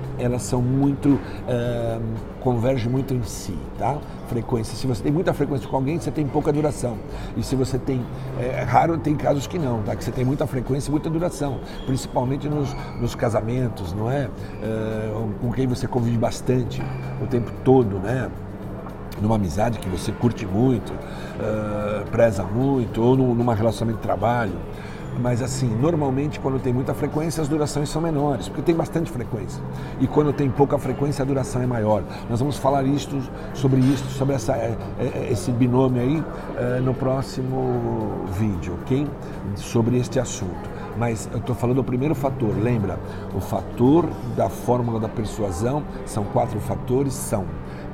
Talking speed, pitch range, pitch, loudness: 165 wpm, 110-135 Hz, 125 Hz, -23 LUFS